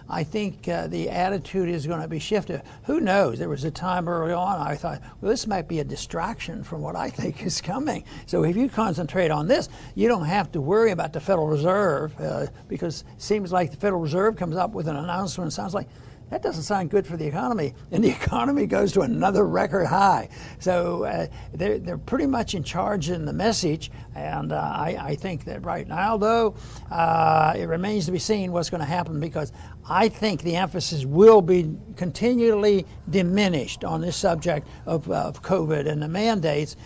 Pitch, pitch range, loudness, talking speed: 180 Hz, 160-205 Hz, -24 LUFS, 205 wpm